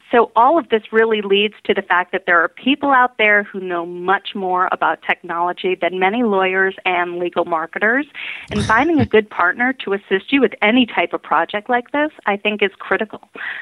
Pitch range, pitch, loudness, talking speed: 180-225 Hz, 200 Hz, -17 LUFS, 205 wpm